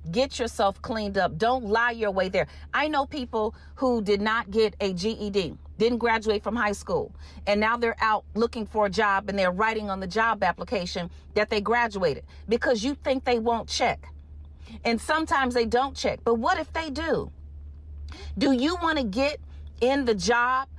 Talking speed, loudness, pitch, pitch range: 190 wpm, -26 LUFS, 220 Hz, 195-245 Hz